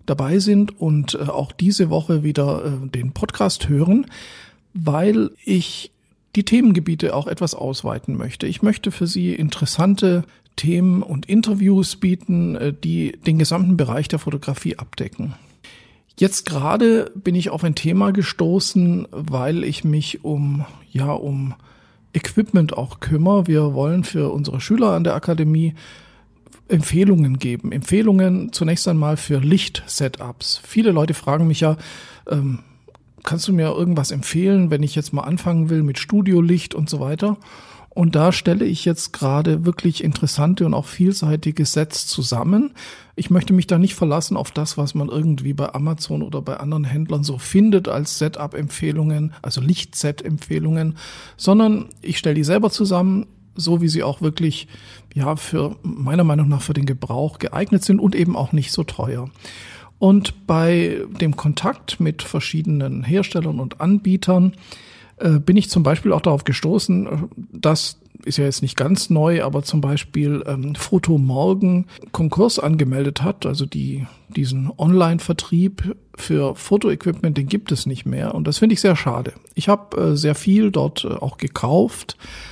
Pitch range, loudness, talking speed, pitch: 145-185 Hz, -19 LUFS, 155 wpm, 160 Hz